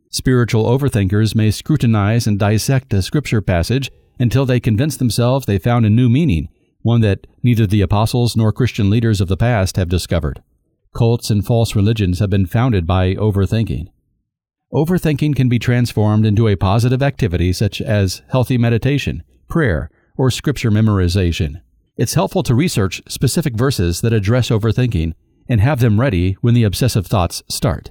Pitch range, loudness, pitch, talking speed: 100-125 Hz, -16 LUFS, 115 Hz, 160 wpm